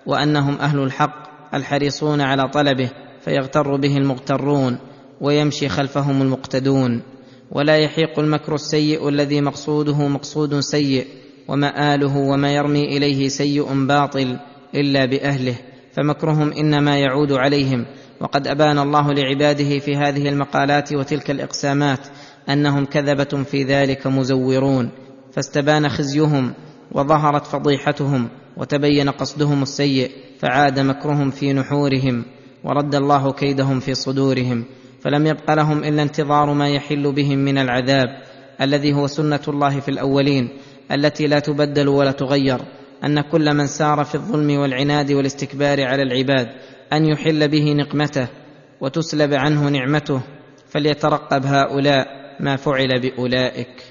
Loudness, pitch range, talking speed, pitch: -18 LUFS, 135-145 Hz, 115 wpm, 140 Hz